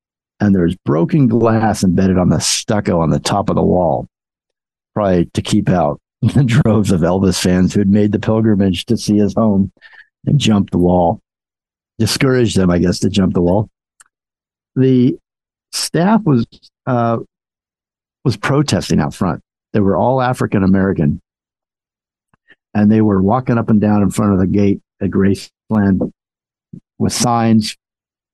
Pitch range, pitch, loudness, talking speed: 95-115 Hz, 105 Hz, -15 LUFS, 155 wpm